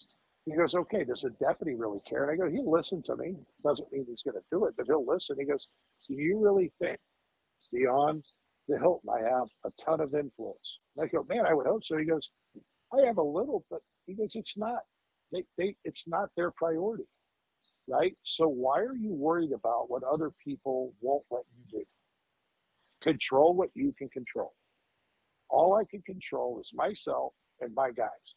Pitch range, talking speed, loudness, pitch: 145-210 Hz, 195 wpm, -31 LUFS, 165 Hz